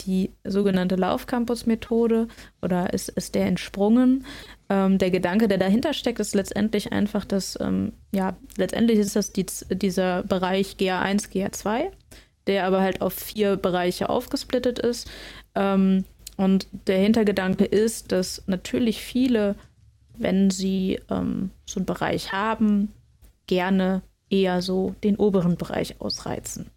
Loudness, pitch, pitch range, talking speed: -24 LUFS, 195 Hz, 190-220 Hz, 130 wpm